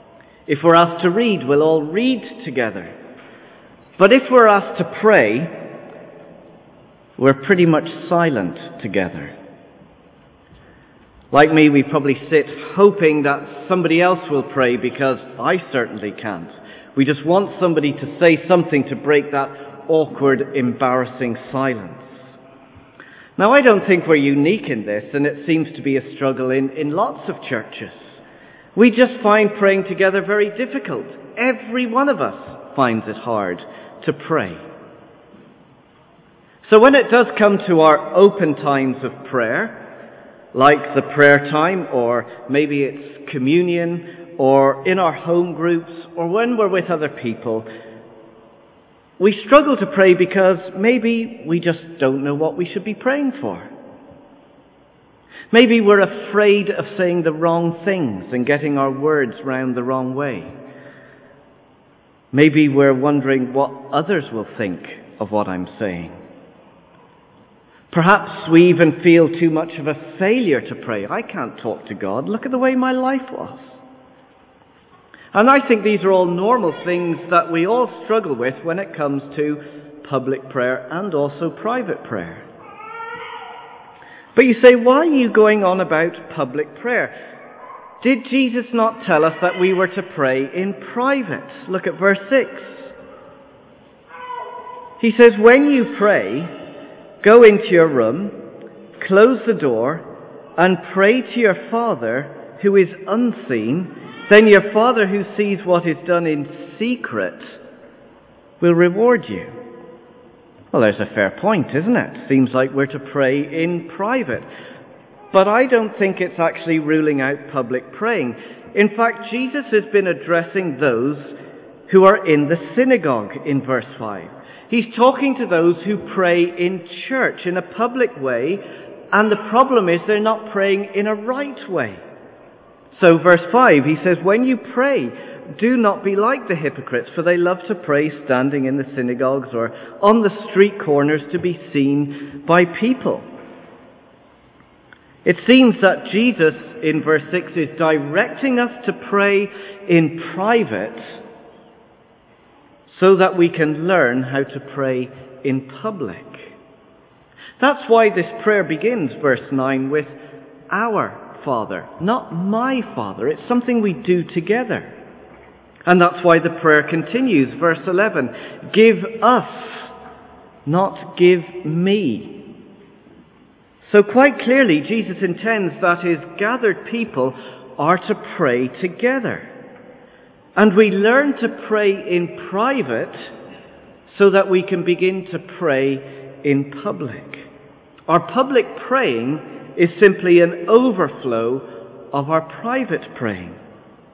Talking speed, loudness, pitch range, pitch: 140 wpm, -17 LUFS, 145-215 Hz, 175 Hz